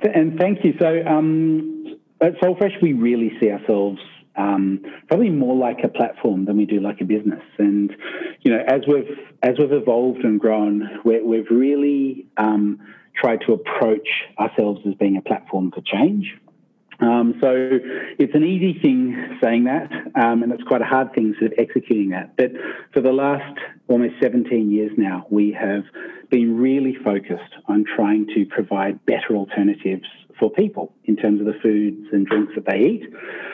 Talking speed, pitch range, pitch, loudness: 170 wpm, 105-145 Hz, 115 Hz, -19 LUFS